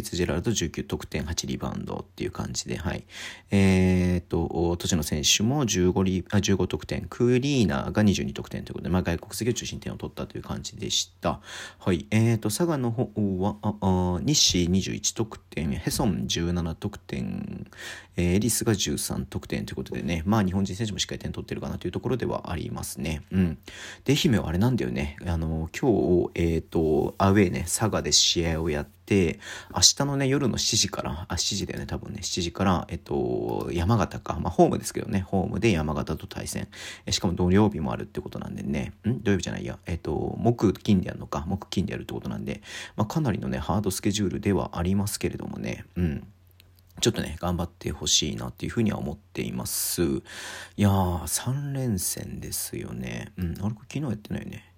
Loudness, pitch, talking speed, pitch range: -26 LUFS, 95 Hz, 370 characters per minute, 85-105 Hz